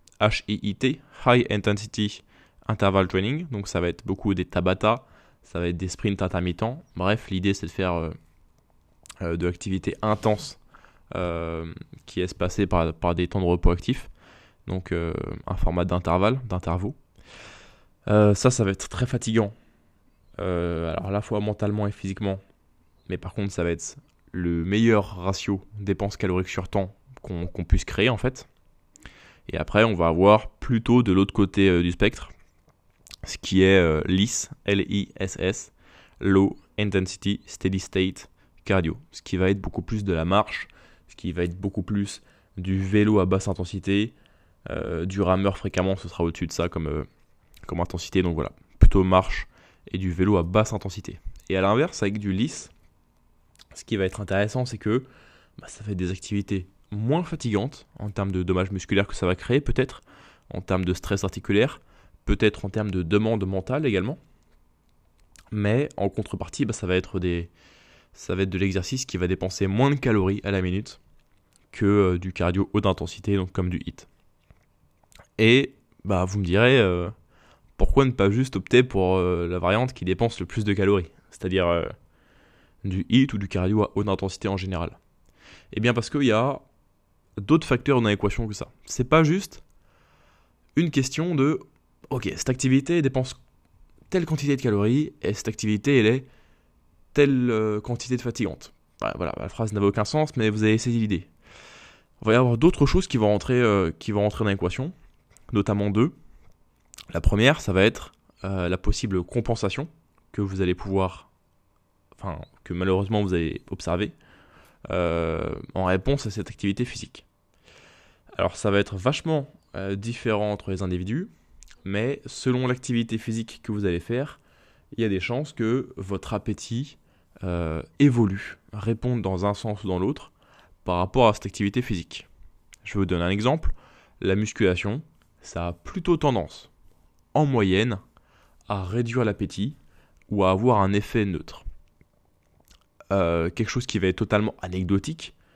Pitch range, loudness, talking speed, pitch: 90-110 Hz, -25 LUFS, 170 wpm, 100 Hz